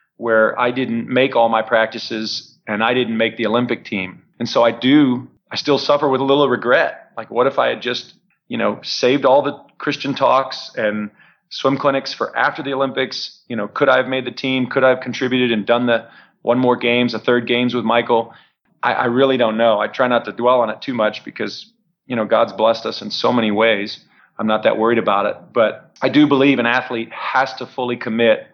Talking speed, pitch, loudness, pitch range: 225 wpm, 125 Hz, -17 LUFS, 115-130 Hz